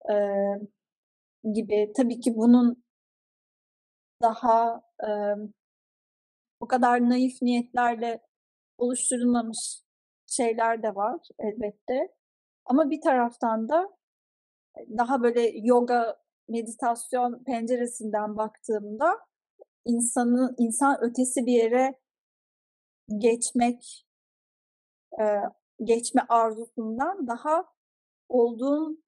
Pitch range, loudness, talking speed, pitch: 225-255 Hz, -26 LUFS, 75 wpm, 240 Hz